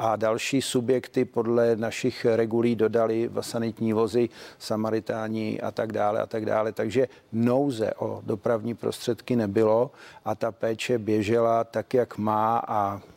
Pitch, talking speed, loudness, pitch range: 115 Hz, 140 wpm, -26 LUFS, 110-120 Hz